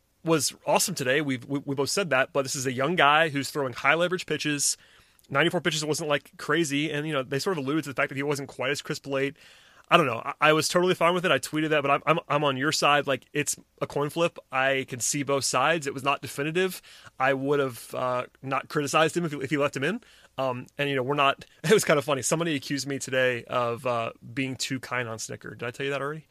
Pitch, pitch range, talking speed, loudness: 140 Hz, 135-155 Hz, 270 wpm, -26 LUFS